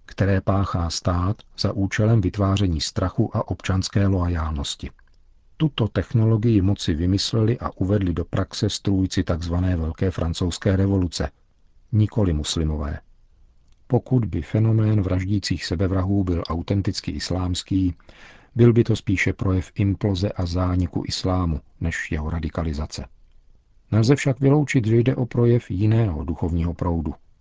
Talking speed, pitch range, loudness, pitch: 120 wpm, 85-110 Hz, -22 LUFS, 95 Hz